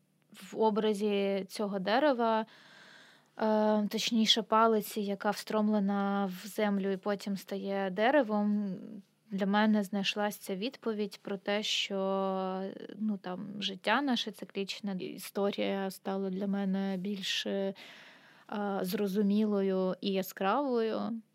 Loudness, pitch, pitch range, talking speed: -32 LUFS, 205 Hz, 195-215 Hz, 95 wpm